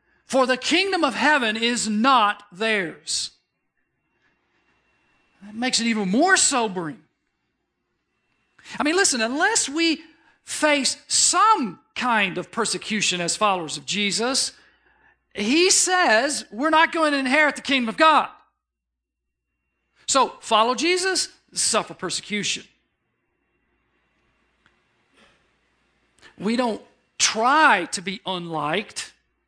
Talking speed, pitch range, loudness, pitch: 100 wpm, 200-305 Hz, -20 LUFS, 235 Hz